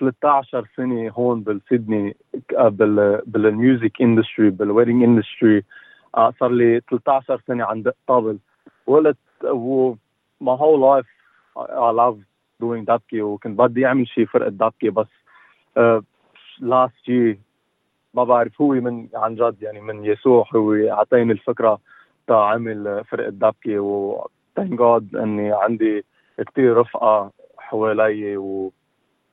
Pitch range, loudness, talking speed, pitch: 105-125 Hz, -19 LUFS, 120 wpm, 115 Hz